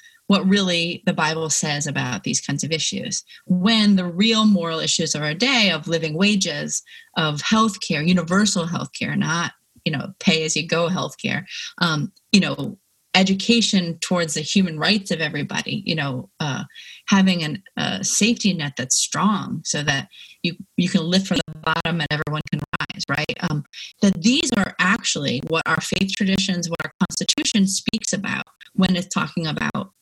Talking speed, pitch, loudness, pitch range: 175 wpm, 180 Hz, -21 LUFS, 160-200 Hz